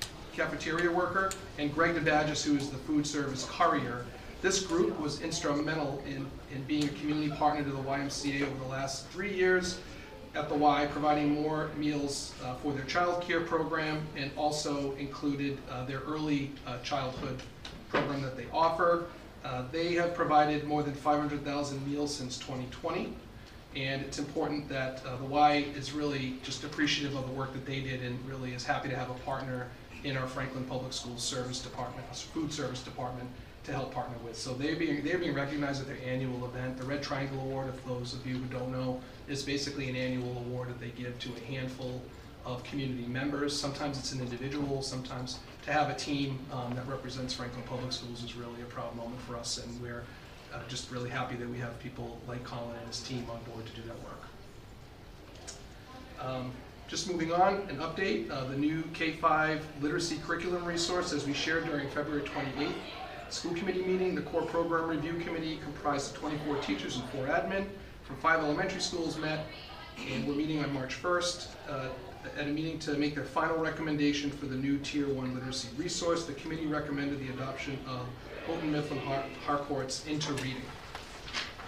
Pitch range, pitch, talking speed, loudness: 125-150 Hz, 140 Hz, 185 wpm, -34 LUFS